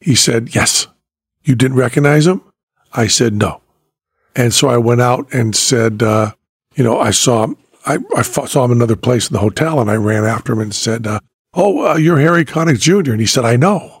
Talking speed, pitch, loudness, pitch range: 220 wpm, 120 Hz, -13 LUFS, 110-145 Hz